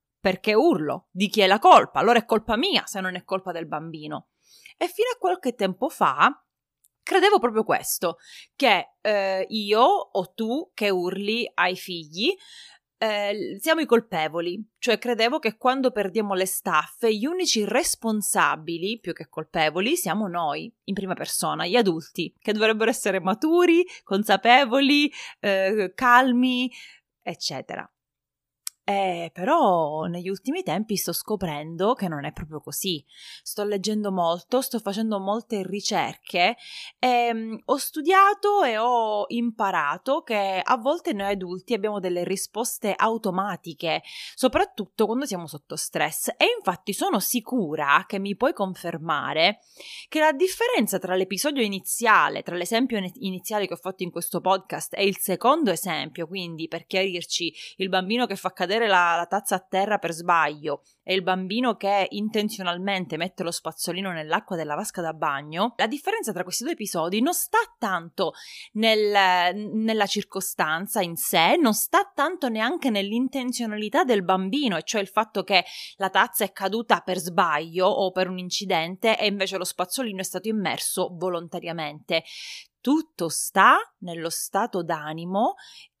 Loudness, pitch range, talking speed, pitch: -24 LUFS, 180-235 Hz, 145 wpm, 200 Hz